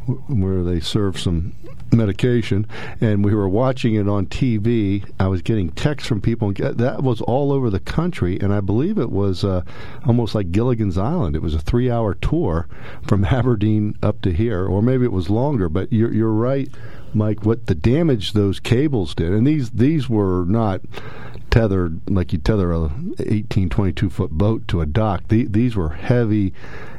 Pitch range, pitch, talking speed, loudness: 95-120 Hz, 110 Hz, 180 wpm, -20 LUFS